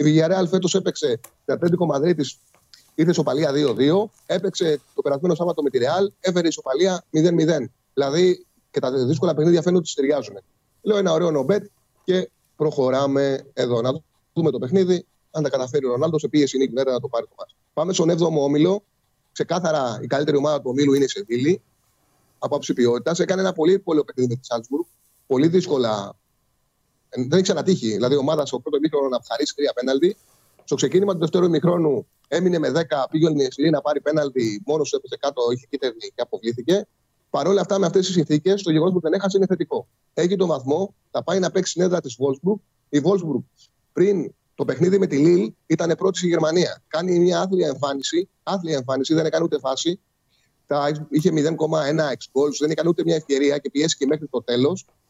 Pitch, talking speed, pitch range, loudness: 160 Hz, 190 wpm, 140-185 Hz, -21 LUFS